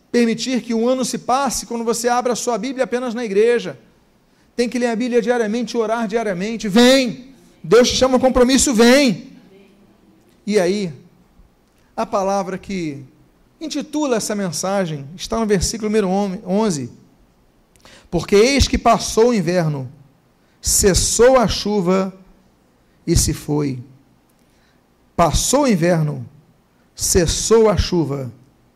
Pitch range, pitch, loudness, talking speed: 170-240 Hz, 215 Hz, -17 LUFS, 125 wpm